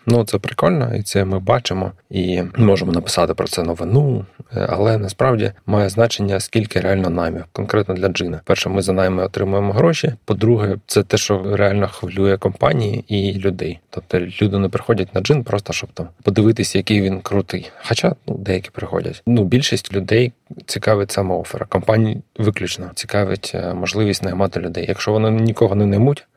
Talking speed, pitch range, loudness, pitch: 160 wpm, 95-115 Hz, -18 LUFS, 100 Hz